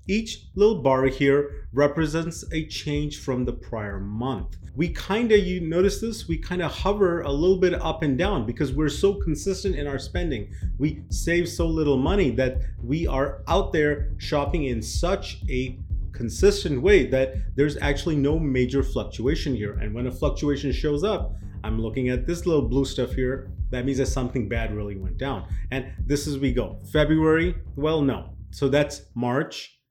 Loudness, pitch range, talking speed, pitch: -25 LUFS, 120-160 Hz, 180 wpm, 135 Hz